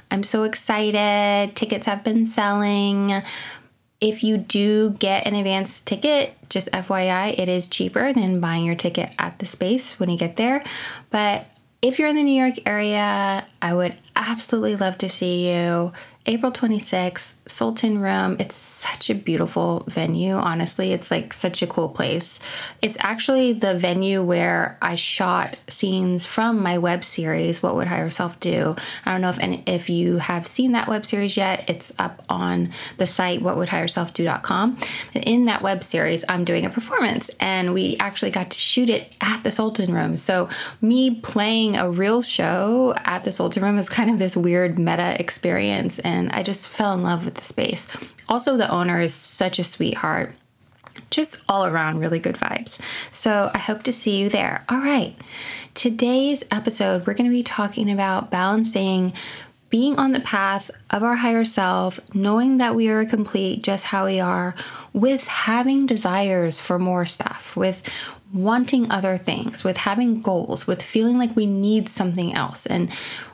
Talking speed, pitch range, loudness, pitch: 175 wpm, 180-230 Hz, -21 LUFS, 200 Hz